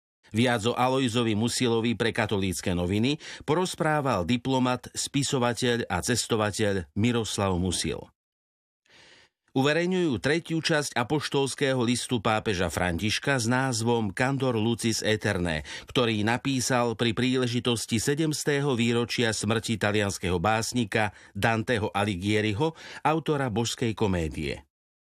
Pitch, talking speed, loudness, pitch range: 120 Hz, 95 wpm, -26 LUFS, 105-130 Hz